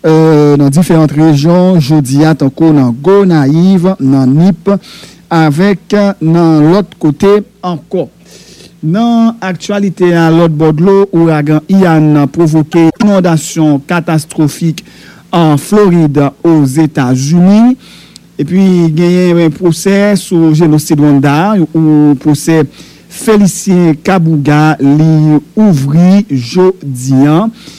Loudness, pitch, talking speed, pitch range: -8 LUFS, 165 Hz, 105 wpm, 150-185 Hz